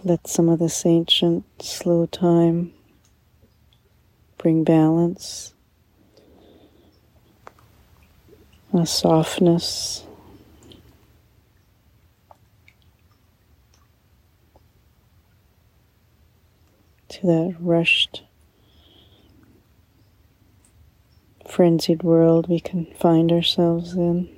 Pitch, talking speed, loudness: 160 Hz, 50 wpm, -20 LUFS